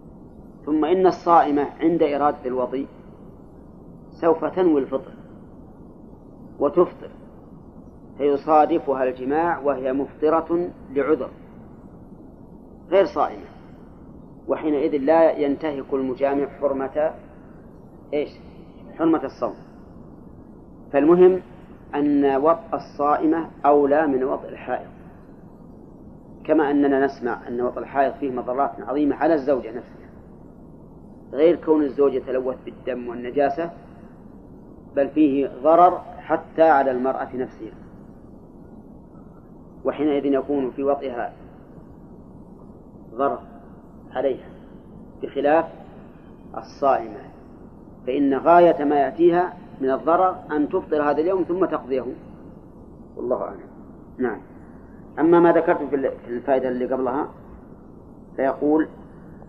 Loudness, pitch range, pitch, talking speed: -21 LUFS, 135-165 Hz, 145 Hz, 90 wpm